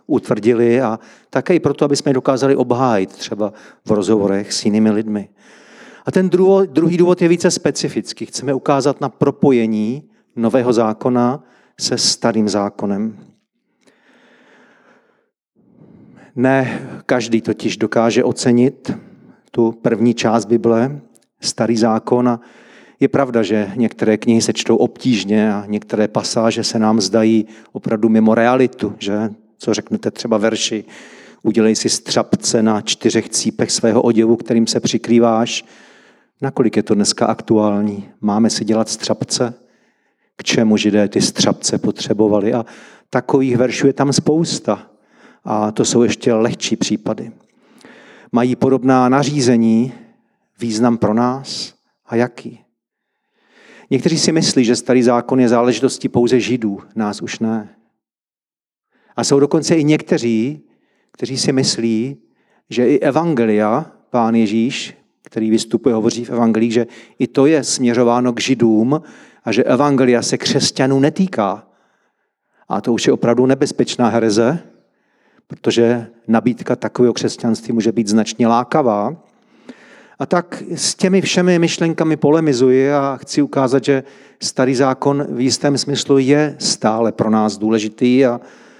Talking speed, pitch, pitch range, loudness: 130 wpm, 120 Hz, 110-135 Hz, -16 LUFS